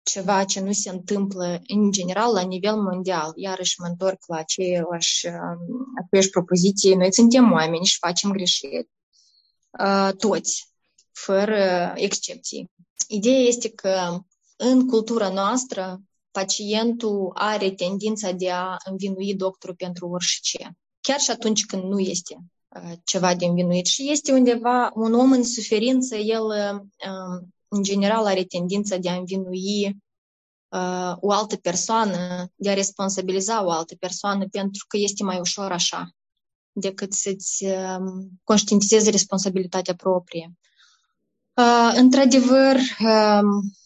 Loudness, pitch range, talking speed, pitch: -21 LUFS, 185-215 Hz, 125 wpm, 195 Hz